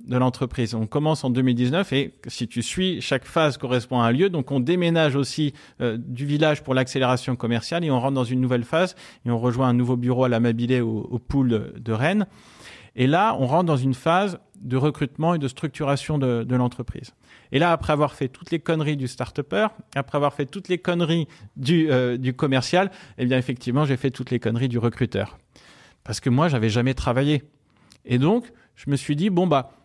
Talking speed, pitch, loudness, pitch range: 215 wpm, 135 Hz, -23 LUFS, 125-155 Hz